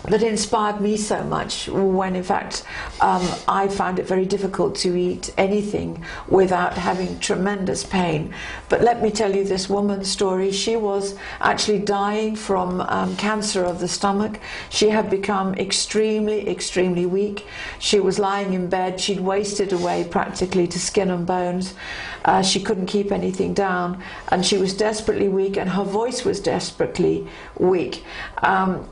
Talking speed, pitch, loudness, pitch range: 160 wpm, 195 Hz, -21 LUFS, 185-205 Hz